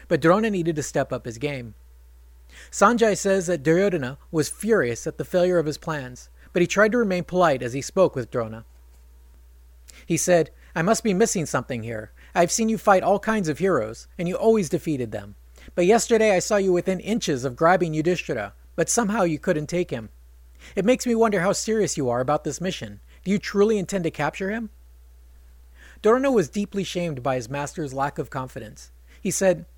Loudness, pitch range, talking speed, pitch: -23 LUFS, 115-195 Hz, 200 wpm, 160 Hz